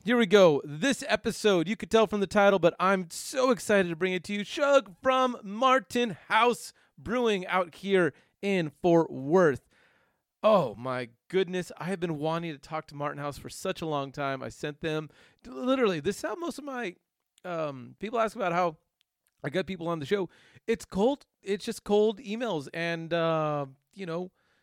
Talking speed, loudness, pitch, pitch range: 190 wpm, -28 LUFS, 185 Hz, 160-215 Hz